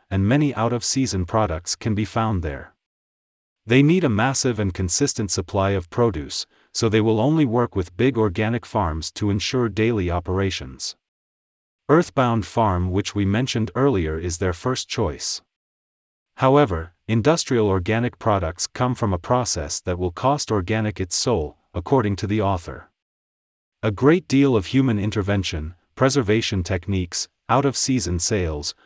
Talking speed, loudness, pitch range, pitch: 150 wpm, -21 LUFS, 90-120 Hz, 105 Hz